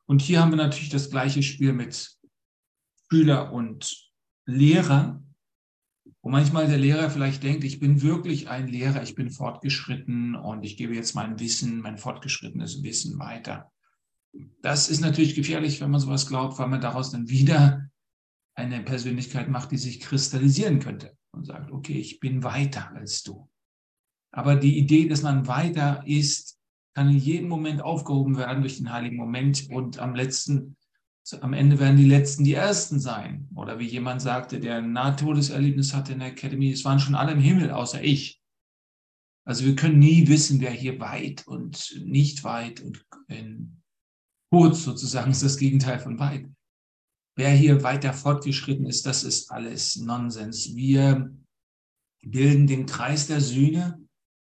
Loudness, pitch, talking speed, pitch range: -23 LUFS, 140 Hz, 160 wpm, 130-145 Hz